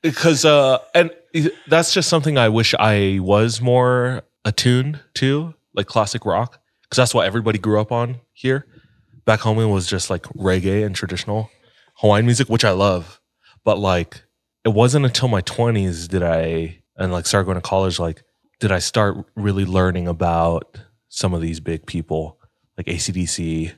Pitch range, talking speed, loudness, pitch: 95-125 Hz, 170 wpm, -19 LUFS, 110 Hz